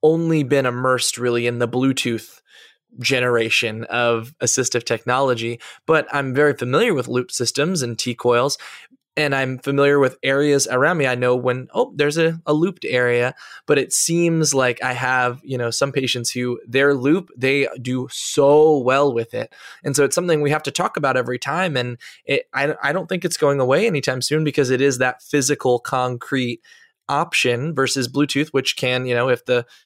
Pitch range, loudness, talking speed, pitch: 125-145 Hz, -19 LUFS, 185 wpm, 130 Hz